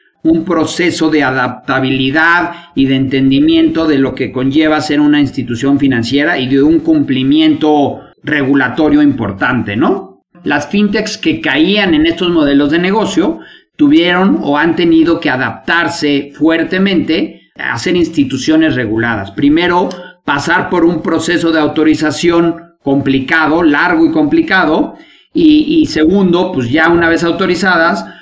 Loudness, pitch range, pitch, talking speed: -11 LUFS, 140-180 Hz, 160 Hz, 130 wpm